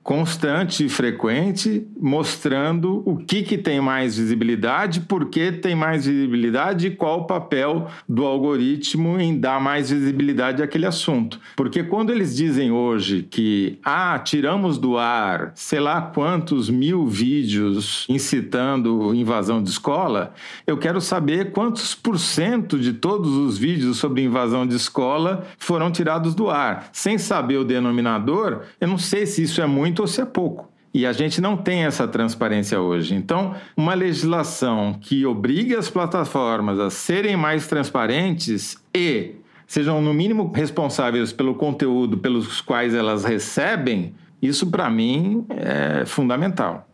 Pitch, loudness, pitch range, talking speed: 150 Hz, -21 LUFS, 125-185 Hz, 145 wpm